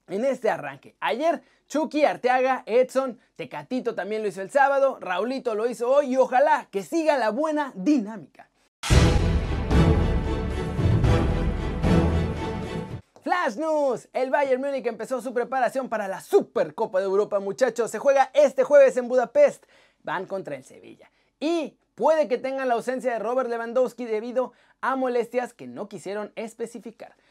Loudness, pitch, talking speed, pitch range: -24 LUFS, 245 Hz, 140 wpm, 195-270 Hz